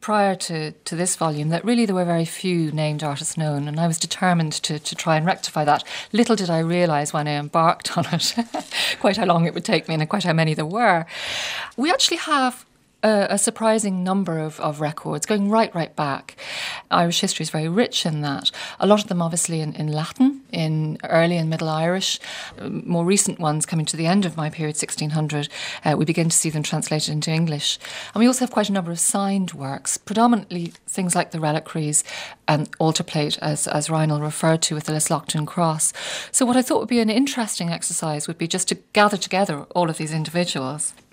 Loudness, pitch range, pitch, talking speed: -21 LUFS, 155-195 Hz, 170 Hz, 215 wpm